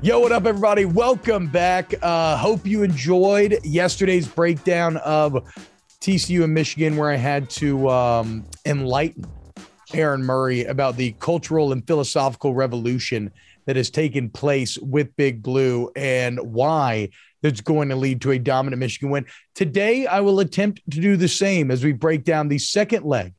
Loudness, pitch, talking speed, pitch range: -20 LUFS, 150 Hz, 160 wpm, 130-180 Hz